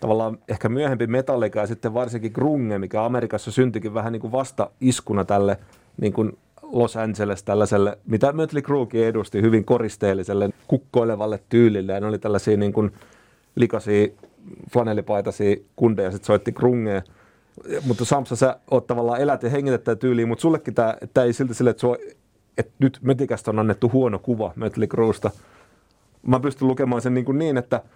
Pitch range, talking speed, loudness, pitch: 105-125 Hz, 160 wpm, -22 LUFS, 115 Hz